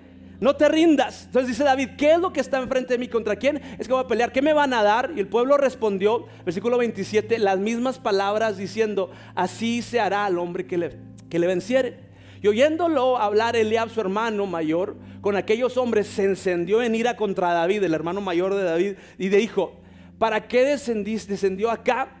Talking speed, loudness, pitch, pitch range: 205 wpm, -23 LUFS, 220 Hz, 190-250 Hz